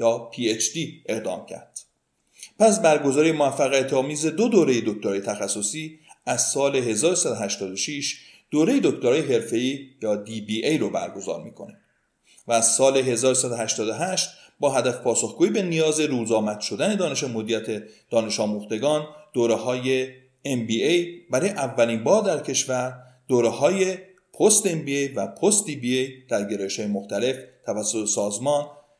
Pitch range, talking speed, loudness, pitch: 115-150 Hz, 145 wpm, -23 LUFS, 130 Hz